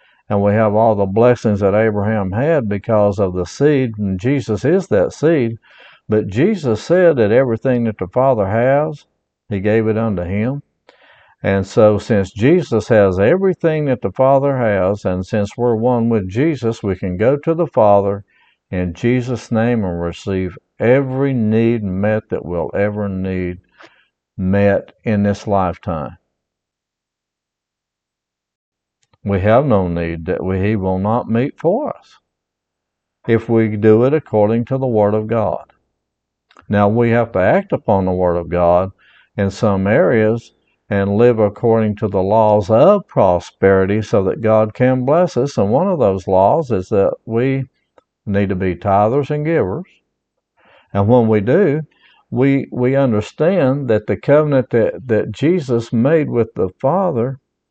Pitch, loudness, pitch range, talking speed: 110 Hz, -16 LUFS, 100-125 Hz, 155 wpm